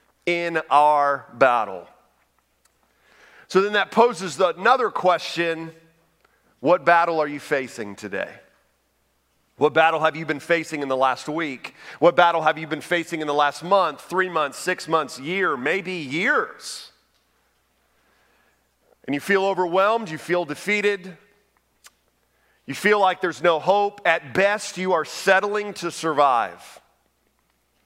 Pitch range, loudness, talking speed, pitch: 145-185 Hz, -21 LUFS, 135 wpm, 165 Hz